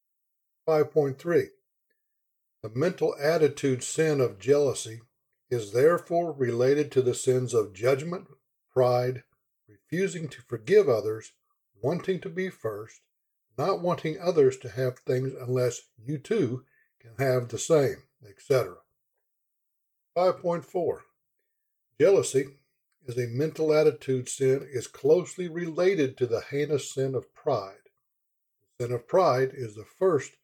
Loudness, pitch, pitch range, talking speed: -27 LUFS, 145 Hz, 125-180 Hz, 130 wpm